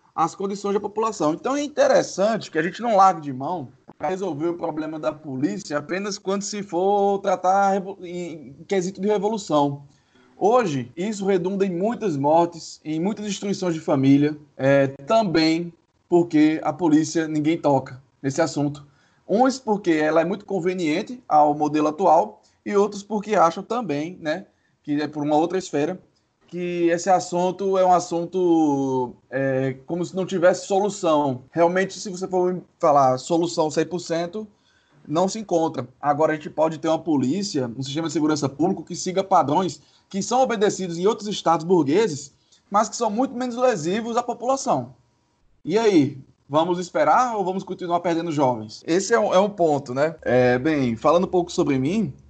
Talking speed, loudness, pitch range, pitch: 165 wpm, -22 LUFS, 150-195 Hz, 170 Hz